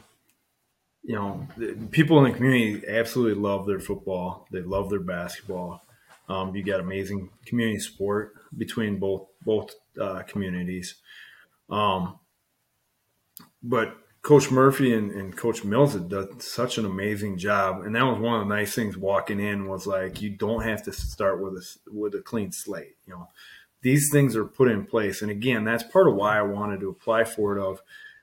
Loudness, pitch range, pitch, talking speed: -25 LUFS, 100-115 Hz, 105 Hz, 175 wpm